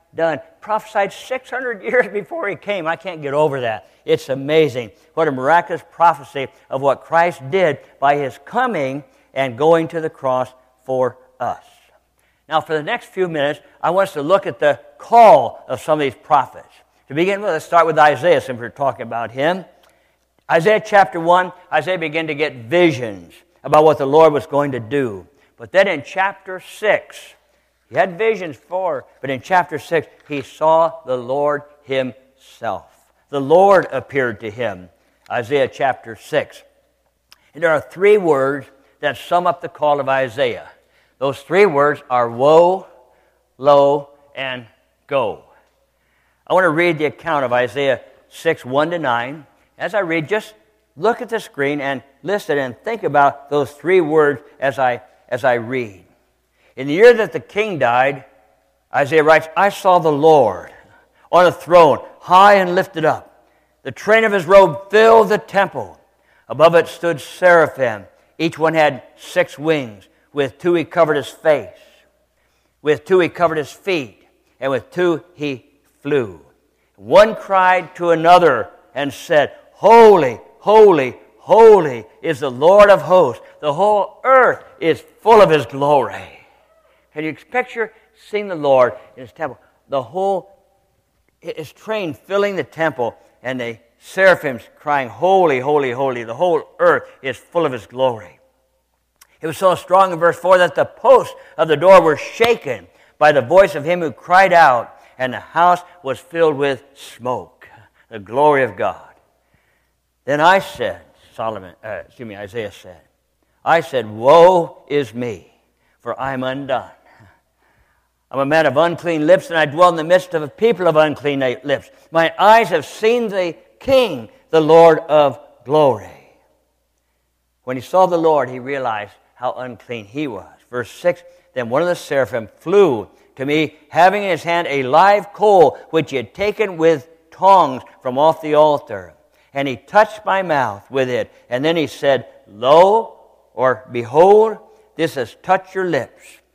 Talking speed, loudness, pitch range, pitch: 165 wpm, -16 LUFS, 135-185 Hz, 160 Hz